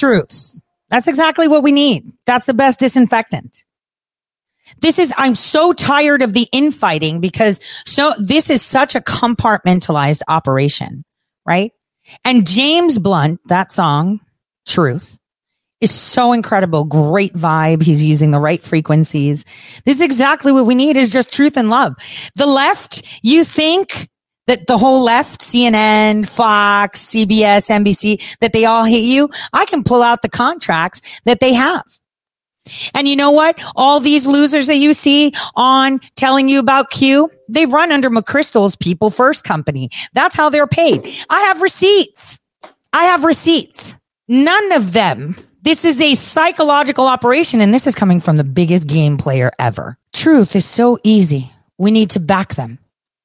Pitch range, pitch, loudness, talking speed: 180-285 Hz, 240 Hz, -12 LUFS, 155 wpm